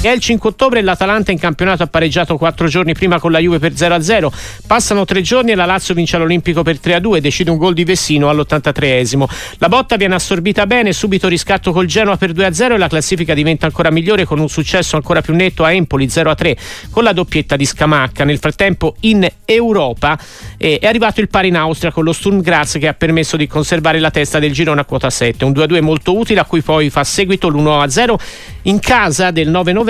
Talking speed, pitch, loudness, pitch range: 215 wpm, 170 Hz, -12 LUFS, 155-195 Hz